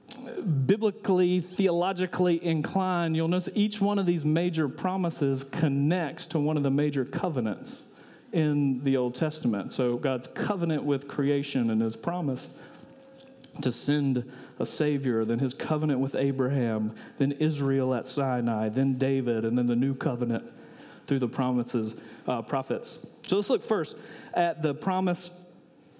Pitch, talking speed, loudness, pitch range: 145 Hz, 145 wpm, -28 LUFS, 130-175 Hz